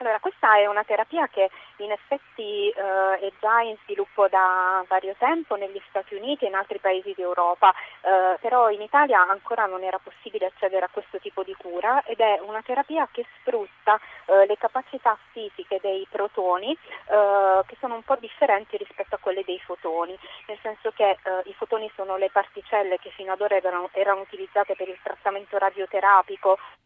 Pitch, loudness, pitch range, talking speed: 200 Hz, -24 LUFS, 190-225 Hz, 180 wpm